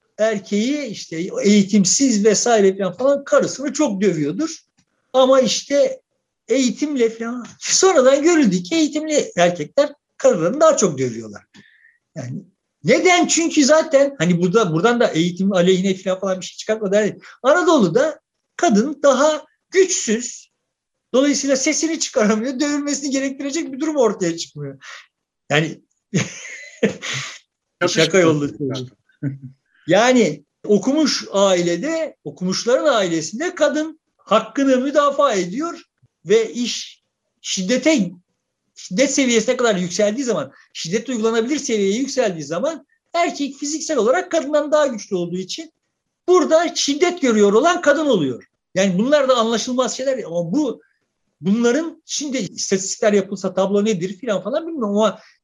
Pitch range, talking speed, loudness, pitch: 195-295 Hz, 115 wpm, -18 LUFS, 245 Hz